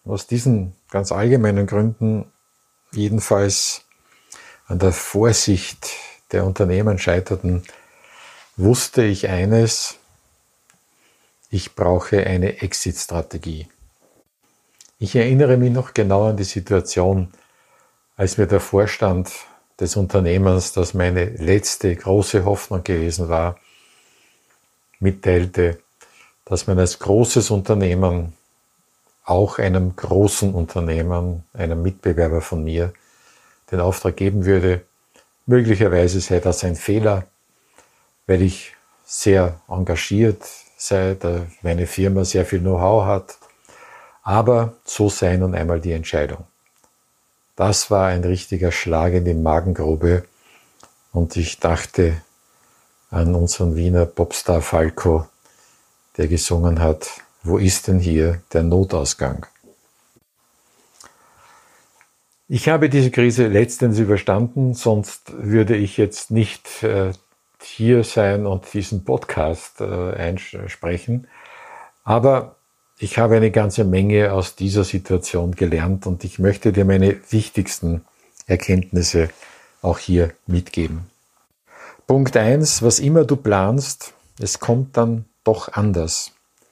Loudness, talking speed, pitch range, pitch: -19 LUFS, 105 wpm, 90-110 Hz, 95 Hz